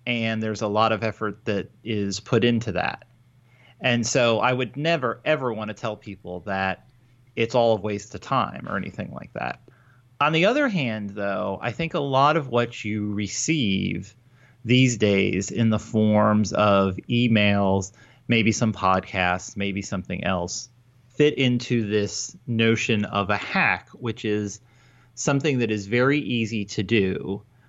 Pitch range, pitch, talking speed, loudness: 105-125 Hz, 115 Hz, 160 wpm, -23 LUFS